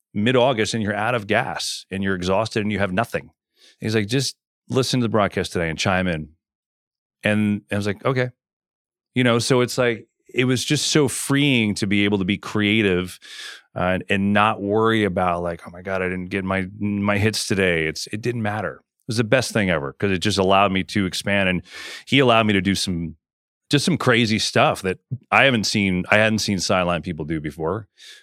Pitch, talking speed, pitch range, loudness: 105 Hz, 220 wpm, 95-115 Hz, -21 LUFS